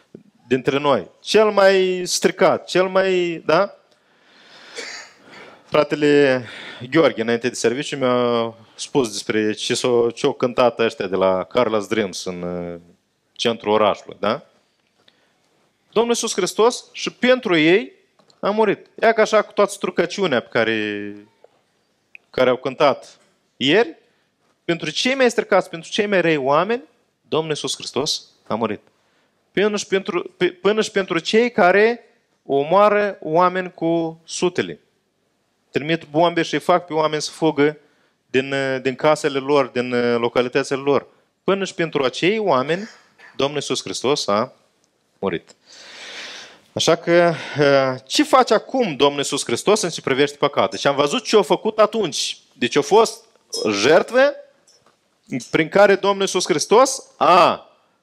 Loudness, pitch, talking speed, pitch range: -19 LUFS, 160 Hz, 130 wpm, 130-195 Hz